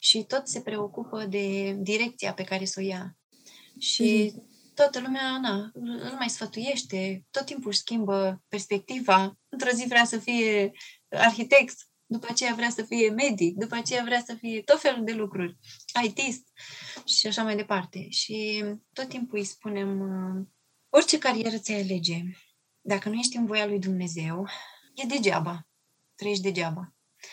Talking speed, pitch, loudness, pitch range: 150 wpm, 215 Hz, -27 LUFS, 195-240 Hz